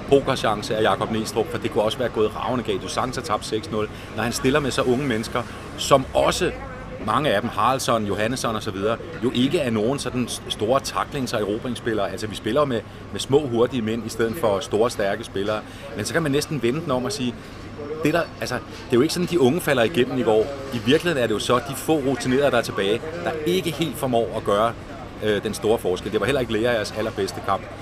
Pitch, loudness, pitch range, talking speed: 115 Hz, -23 LUFS, 110-135 Hz, 240 wpm